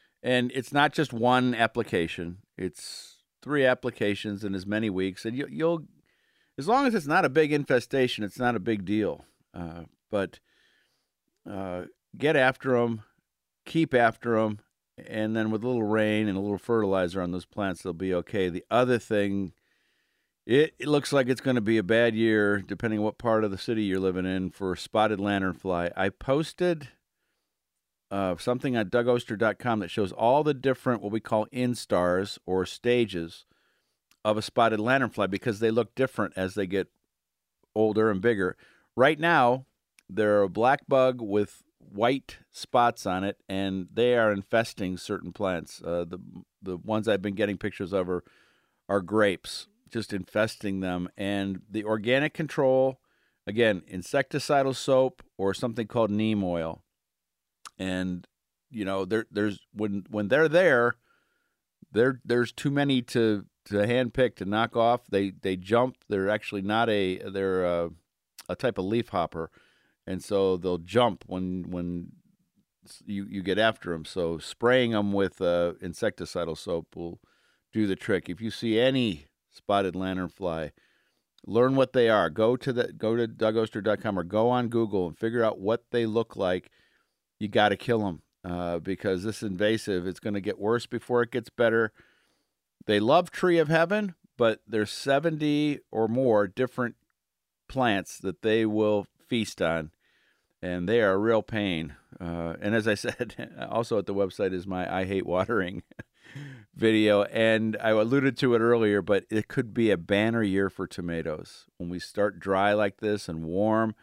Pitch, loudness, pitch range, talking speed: 105 Hz, -27 LUFS, 95-120 Hz, 165 wpm